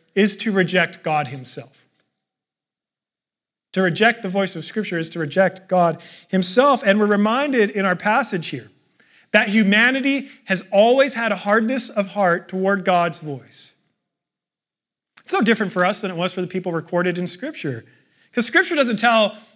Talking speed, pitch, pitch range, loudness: 165 wpm, 195 Hz, 175-225 Hz, -18 LUFS